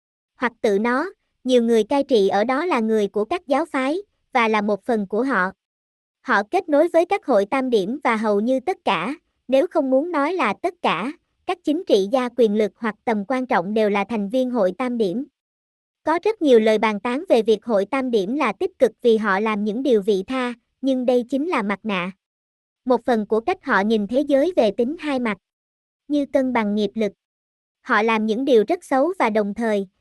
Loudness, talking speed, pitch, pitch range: -21 LUFS, 220 wpm, 245 Hz, 215-285 Hz